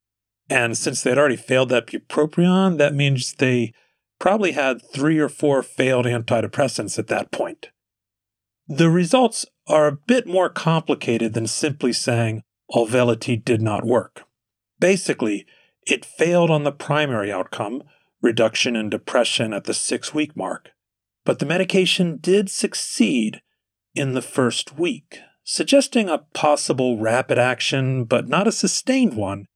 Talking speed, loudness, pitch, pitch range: 140 wpm, -20 LUFS, 135 Hz, 115-175 Hz